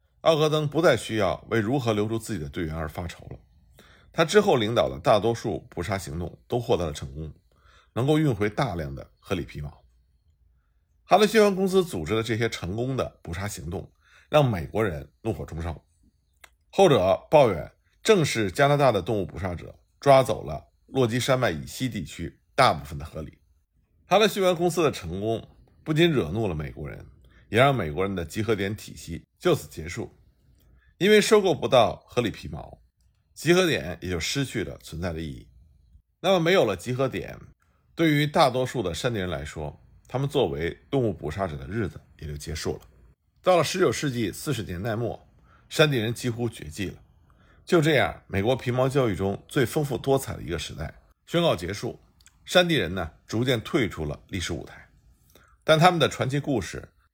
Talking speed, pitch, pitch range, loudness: 275 characters per minute, 105 Hz, 80-135 Hz, -25 LUFS